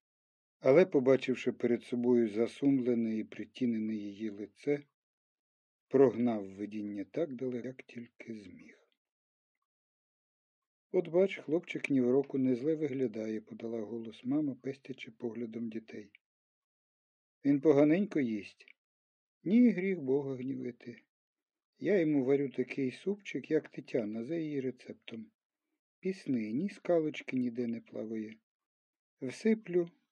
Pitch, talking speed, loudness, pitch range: 130 Hz, 110 wpm, -33 LUFS, 115-155 Hz